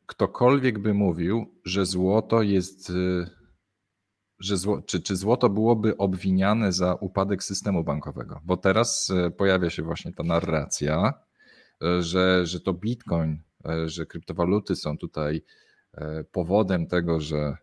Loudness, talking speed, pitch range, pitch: -25 LUFS, 120 wpm, 85-100 Hz, 95 Hz